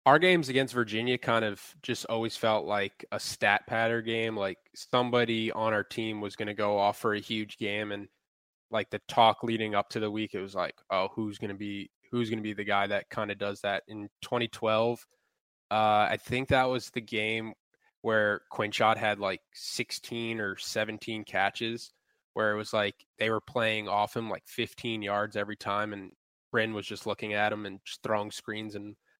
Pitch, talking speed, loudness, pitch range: 110 Hz, 205 wpm, -30 LUFS, 105-115 Hz